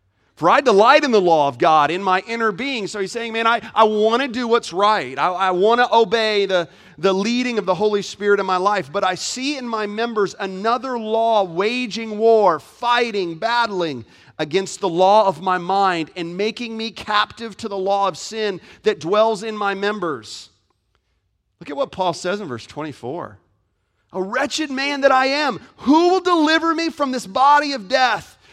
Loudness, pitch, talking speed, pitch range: -18 LUFS, 210 Hz, 195 wpm, 185-235 Hz